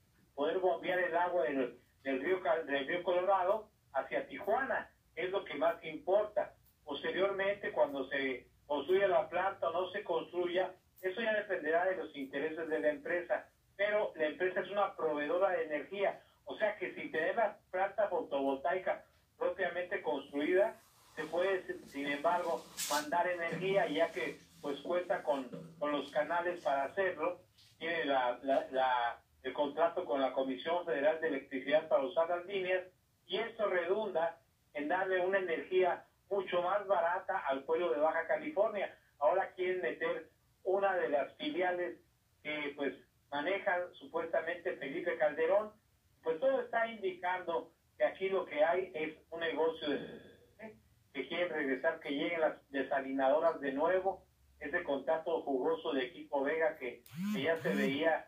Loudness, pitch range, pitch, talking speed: -35 LUFS, 150-190 Hz, 170 Hz, 150 wpm